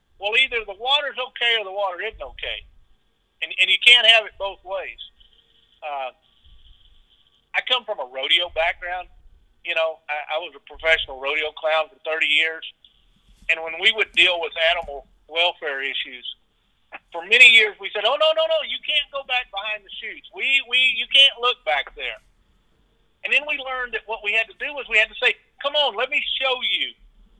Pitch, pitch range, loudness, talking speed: 205 Hz, 160-250 Hz, -19 LUFS, 195 wpm